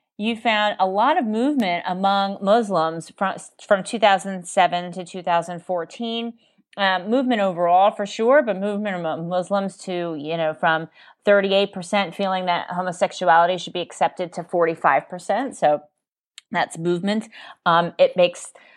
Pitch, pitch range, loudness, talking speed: 190 Hz, 175-205 Hz, -21 LUFS, 130 wpm